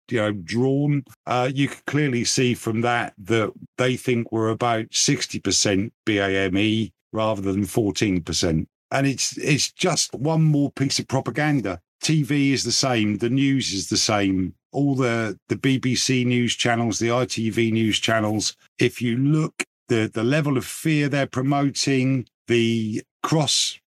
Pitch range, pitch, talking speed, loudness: 110-135 Hz, 120 Hz, 155 wpm, -22 LUFS